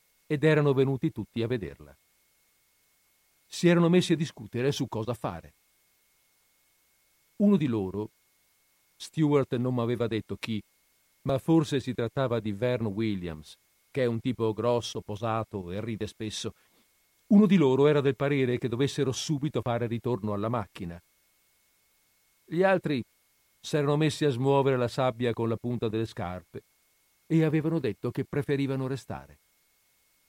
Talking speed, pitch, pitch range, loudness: 145 wpm, 125 Hz, 110-140 Hz, -28 LUFS